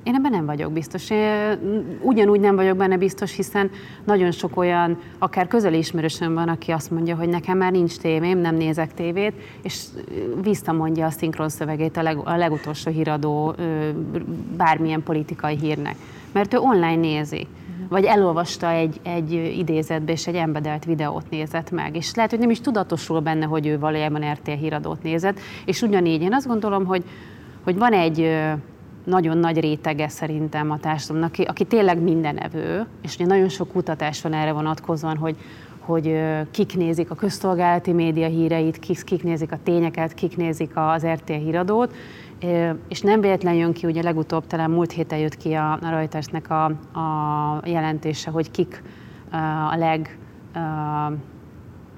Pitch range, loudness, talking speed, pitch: 155-180 Hz, -22 LUFS, 160 wpm, 165 Hz